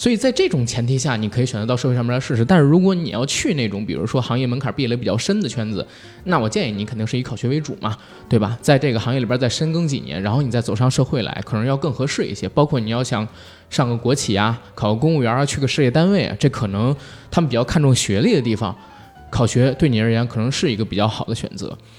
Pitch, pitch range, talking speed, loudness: 125 Hz, 110-140 Hz, 395 characters per minute, -19 LUFS